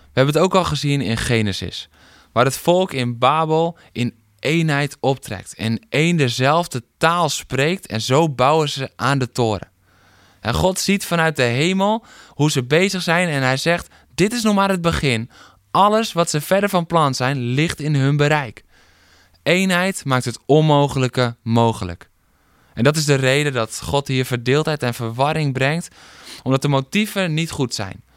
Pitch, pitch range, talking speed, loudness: 135 Hz, 115-165 Hz, 175 wpm, -18 LUFS